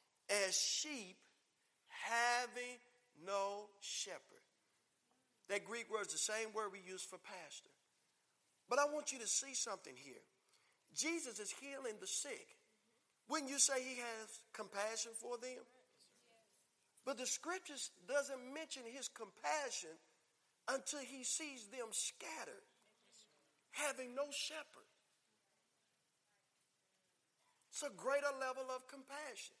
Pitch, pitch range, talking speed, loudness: 255 Hz, 215-285 Hz, 120 wpm, -43 LUFS